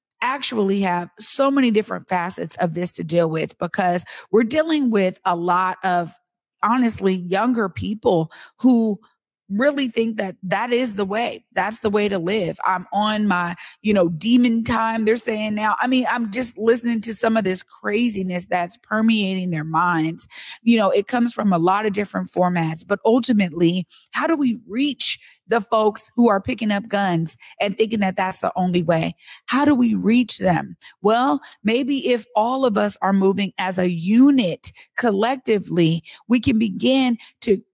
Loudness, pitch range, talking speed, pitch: -20 LUFS, 185-235 Hz, 175 wpm, 215 Hz